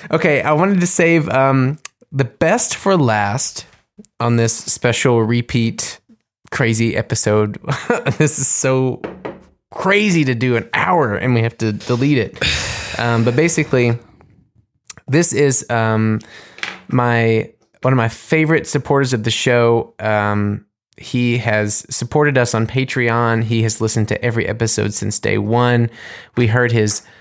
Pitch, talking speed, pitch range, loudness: 120 Hz, 140 wpm, 110-140 Hz, -16 LUFS